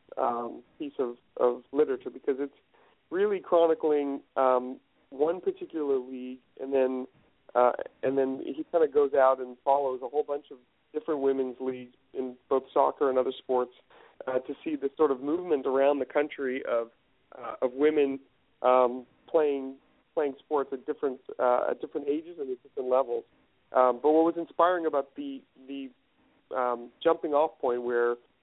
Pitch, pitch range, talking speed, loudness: 140 Hz, 130-160 Hz, 165 wpm, -28 LUFS